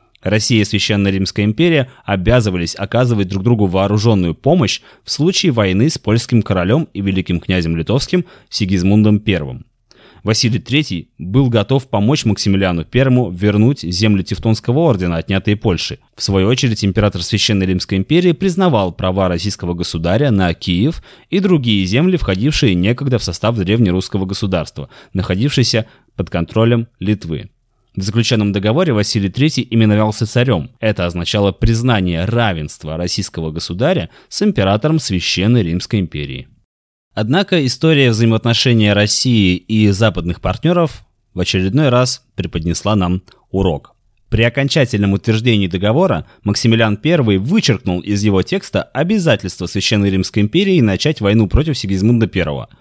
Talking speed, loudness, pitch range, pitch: 125 wpm, -15 LUFS, 95-125 Hz, 105 Hz